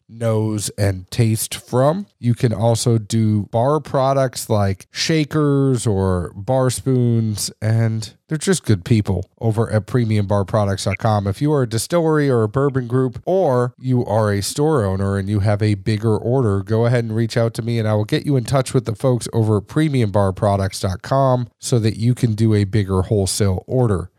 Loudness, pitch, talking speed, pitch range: -19 LUFS, 115 Hz, 180 wpm, 105-130 Hz